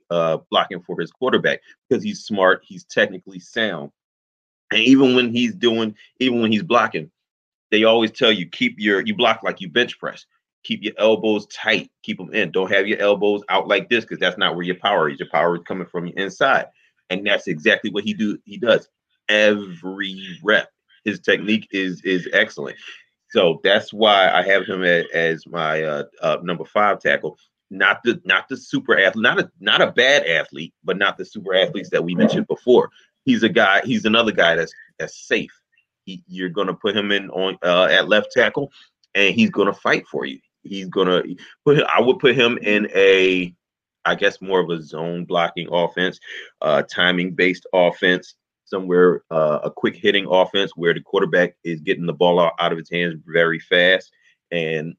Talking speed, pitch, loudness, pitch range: 195 wpm, 95 Hz, -19 LUFS, 85-105 Hz